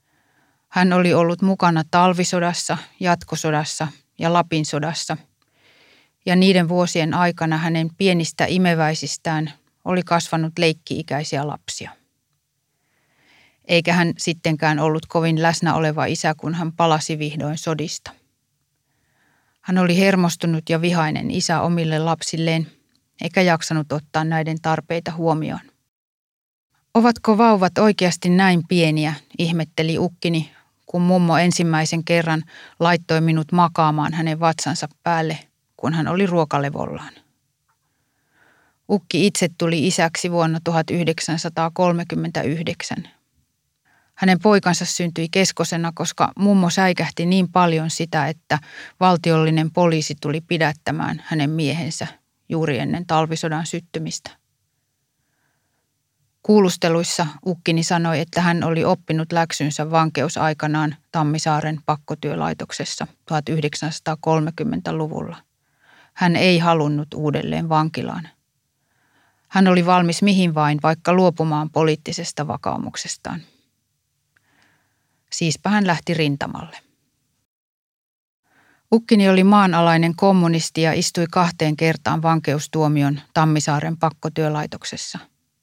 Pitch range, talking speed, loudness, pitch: 155-175 Hz, 95 wpm, -19 LUFS, 165 Hz